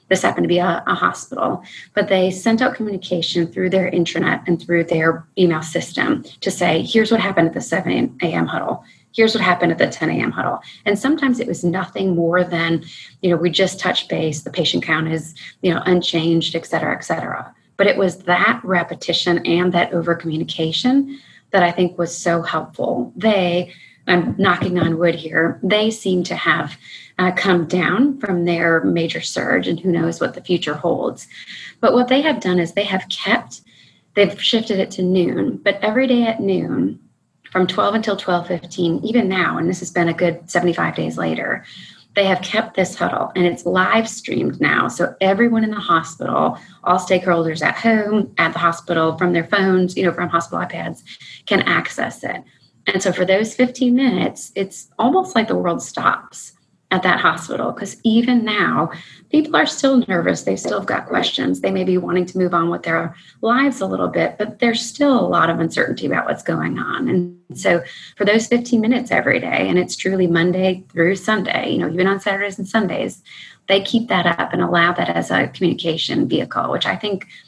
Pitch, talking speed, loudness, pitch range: 180 Hz, 195 wpm, -18 LUFS, 170-210 Hz